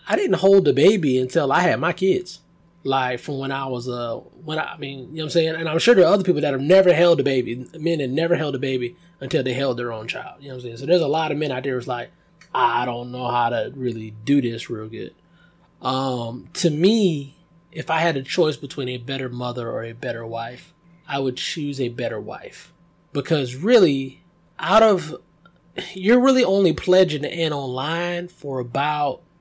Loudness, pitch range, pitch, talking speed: -21 LUFS, 130-175 Hz, 150 Hz, 225 wpm